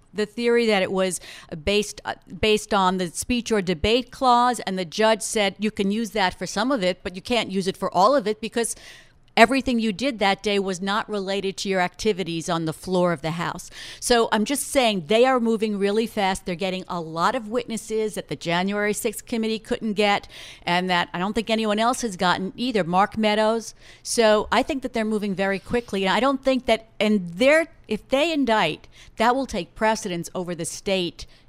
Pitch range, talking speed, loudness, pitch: 185-230 Hz, 210 wpm, -23 LUFS, 210 Hz